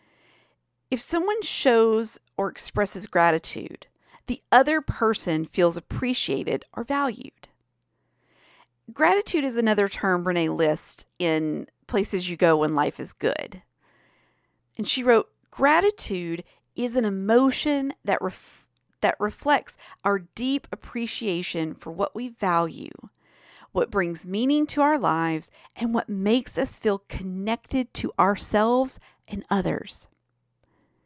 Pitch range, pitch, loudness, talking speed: 180-255 Hz, 215 Hz, -25 LUFS, 120 wpm